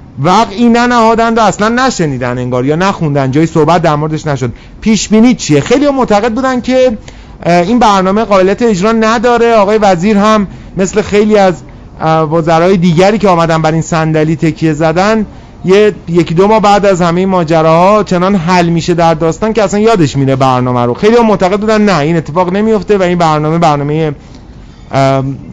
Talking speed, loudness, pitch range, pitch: 165 wpm, -9 LUFS, 160-215 Hz, 185 Hz